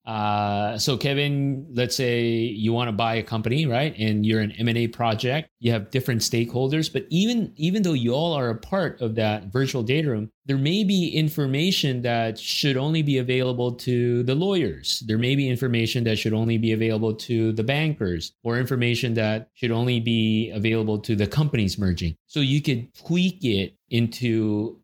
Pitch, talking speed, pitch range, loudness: 120 Hz, 185 wpm, 110-140 Hz, -23 LUFS